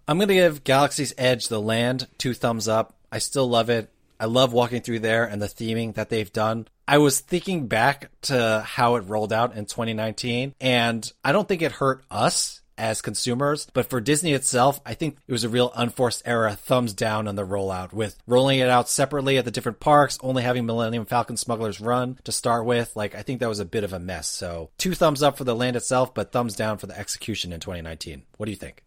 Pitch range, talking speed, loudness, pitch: 110-130 Hz, 230 wpm, -23 LUFS, 120 Hz